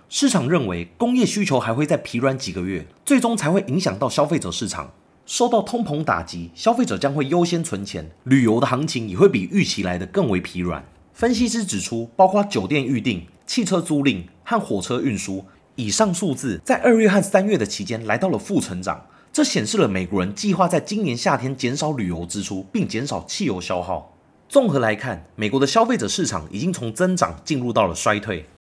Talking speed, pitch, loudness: 310 characters per minute, 140 Hz, -21 LUFS